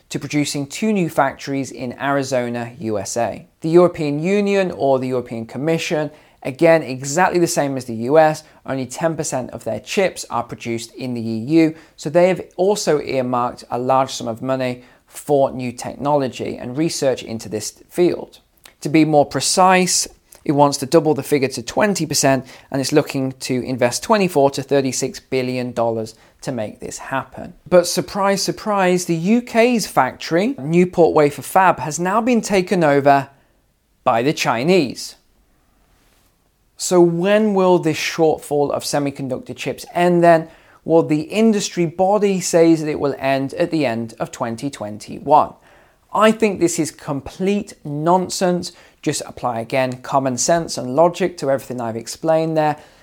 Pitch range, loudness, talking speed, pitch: 130-175 Hz, -18 LUFS, 150 wpm, 150 Hz